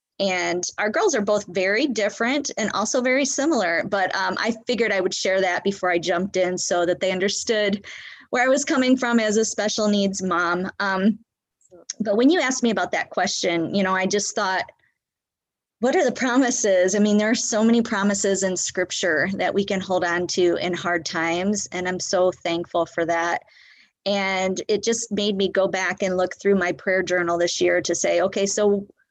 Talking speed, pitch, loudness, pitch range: 200 wpm, 195 Hz, -22 LUFS, 180-215 Hz